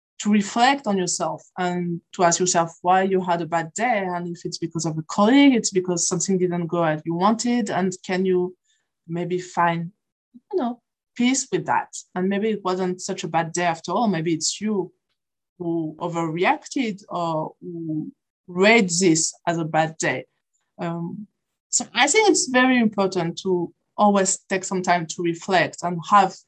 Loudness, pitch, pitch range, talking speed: -22 LUFS, 185 Hz, 170-210 Hz, 175 wpm